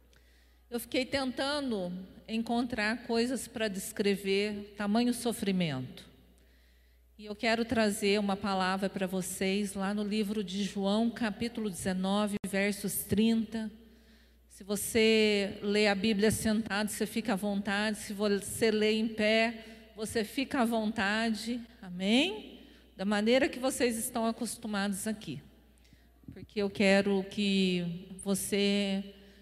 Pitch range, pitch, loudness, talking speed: 195-225 Hz, 210 Hz, -31 LUFS, 120 wpm